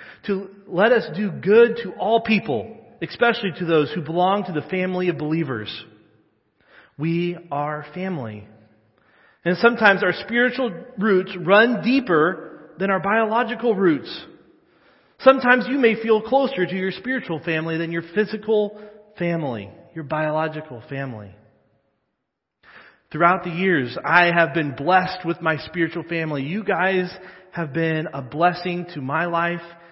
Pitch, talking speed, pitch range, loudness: 180 Hz, 135 wpm, 160-210 Hz, -21 LUFS